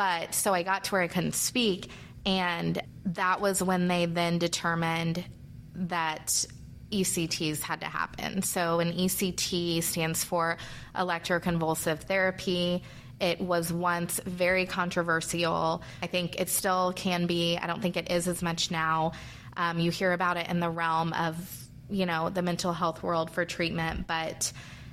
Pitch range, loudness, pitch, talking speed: 165-180 Hz, -29 LUFS, 175 Hz, 155 wpm